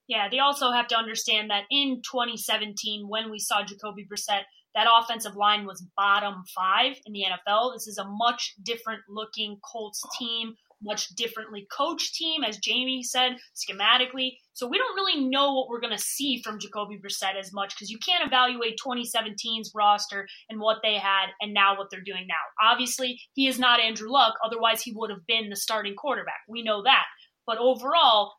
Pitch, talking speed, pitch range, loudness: 225 Hz, 190 wpm, 205-245 Hz, -25 LUFS